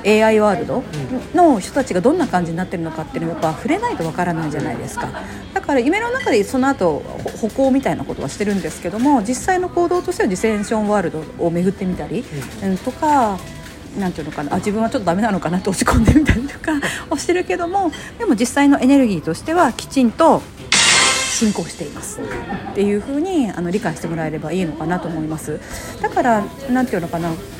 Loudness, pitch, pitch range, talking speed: -18 LUFS, 215 Hz, 175-285 Hz, 450 characters per minute